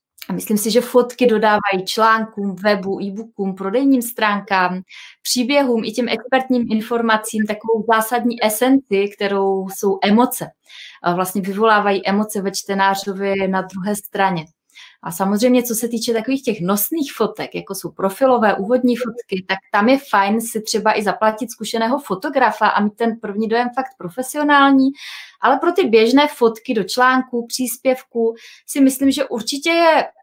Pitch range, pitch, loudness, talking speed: 200-250 Hz, 225 Hz, -18 LUFS, 150 wpm